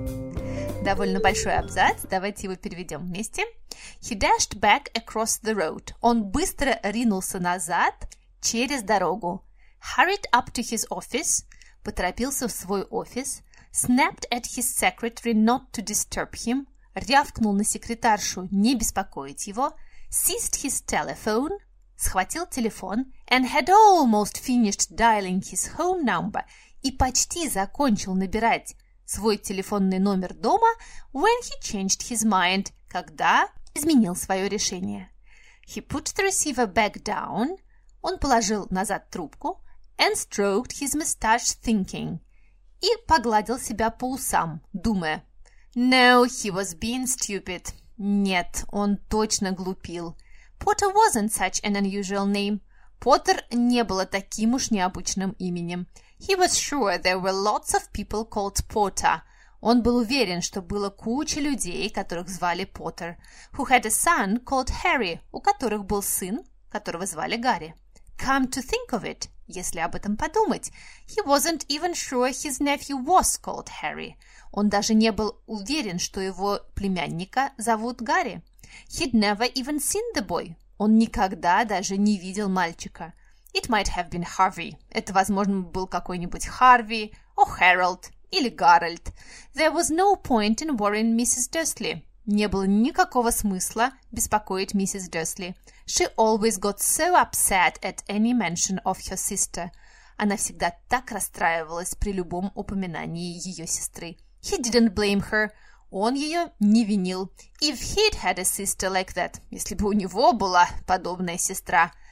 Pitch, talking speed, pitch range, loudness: 215 Hz, 140 wpm, 190-255 Hz, -24 LUFS